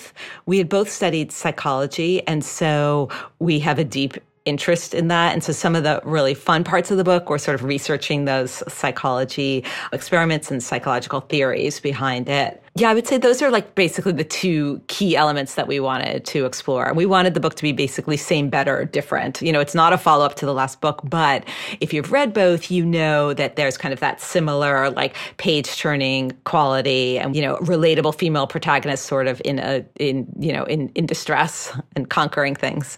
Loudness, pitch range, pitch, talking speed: -20 LUFS, 140-170 Hz, 150 Hz, 200 wpm